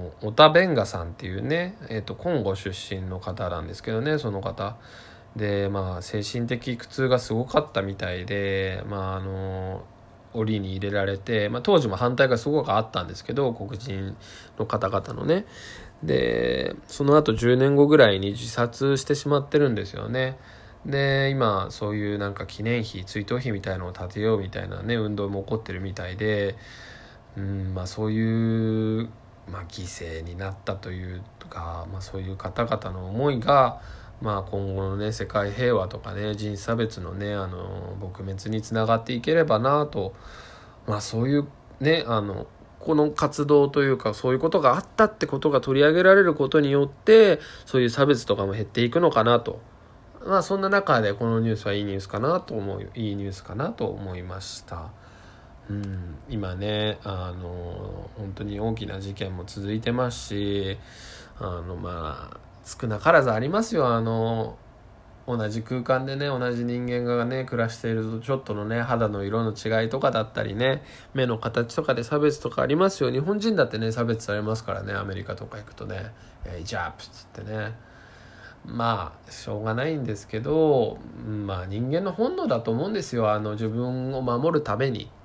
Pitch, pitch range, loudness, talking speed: 110 Hz, 100-125 Hz, -25 LUFS, 335 characters per minute